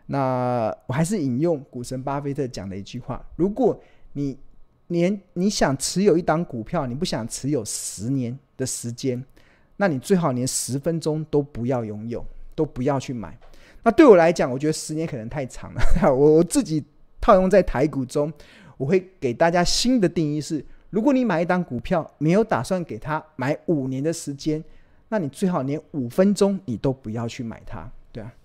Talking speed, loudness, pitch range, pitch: 270 characters per minute, -23 LUFS, 125-170 Hz, 145 Hz